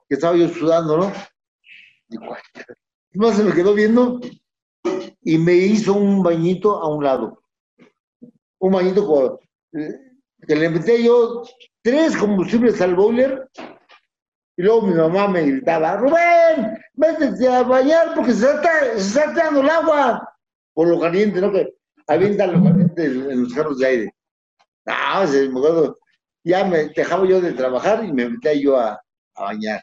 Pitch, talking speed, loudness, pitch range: 200 Hz, 155 wpm, -17 LUFS, 165-245 Hz